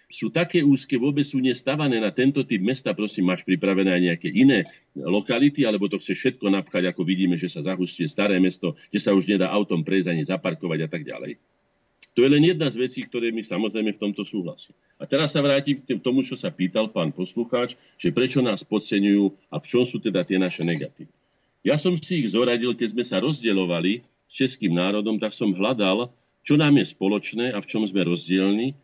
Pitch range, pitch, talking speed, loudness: 95-130 Hz, 110 Hz, 205 wpm, -23 LUFS